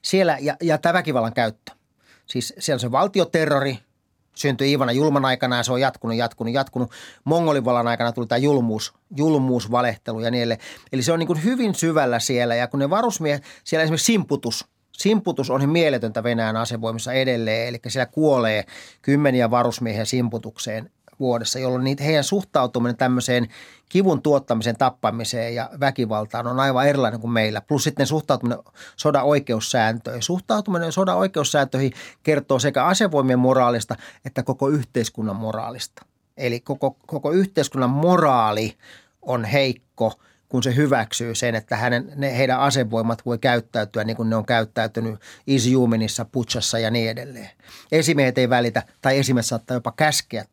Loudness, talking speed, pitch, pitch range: -21 LUFS, 150 wpm, 125 Hz, 115-145 Hz